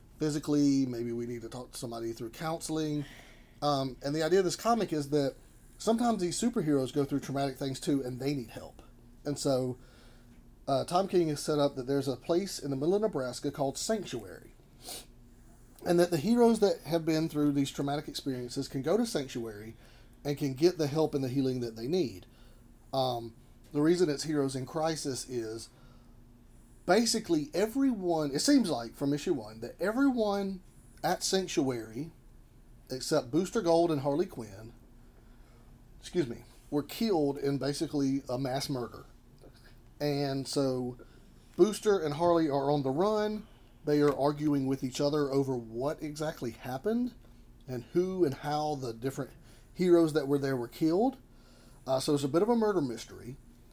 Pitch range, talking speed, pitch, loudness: 125-160 Hz, 165 wpm, 140 Hz, -31 LUFS